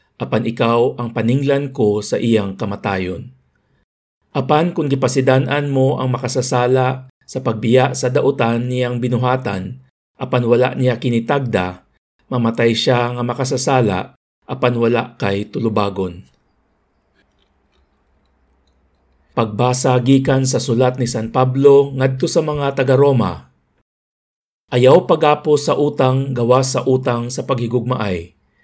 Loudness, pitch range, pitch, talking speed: -16 LUFS, 115-130 Hz, 125 Hz, 110 wpm